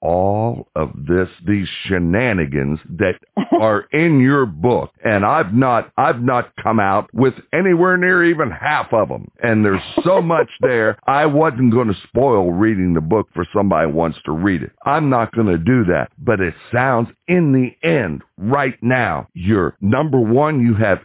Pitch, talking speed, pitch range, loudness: 115 Hz, 180 wpm, 95-135 Hz, -16 LUFS